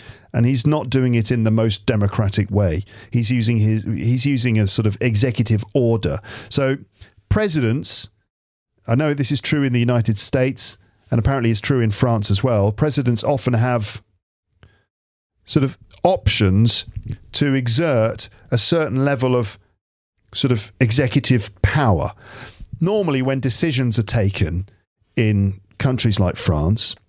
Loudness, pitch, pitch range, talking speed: -18 LUFS, 115 Hz, 105-130 Hz, 140 wpm